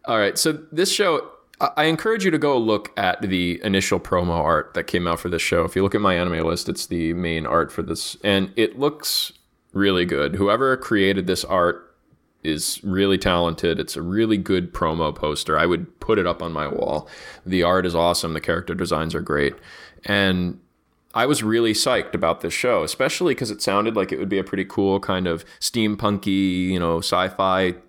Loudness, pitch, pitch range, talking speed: -21 LUFS, 95 Hz, 85-105 Hz, 205 wpm